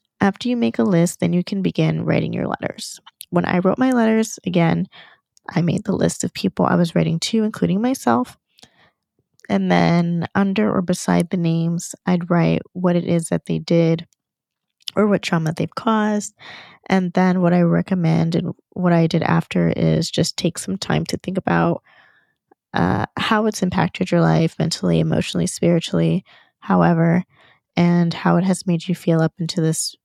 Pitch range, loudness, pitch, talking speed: 165-190 Hz, -19 LUFS, 175 Hz, 175 wpm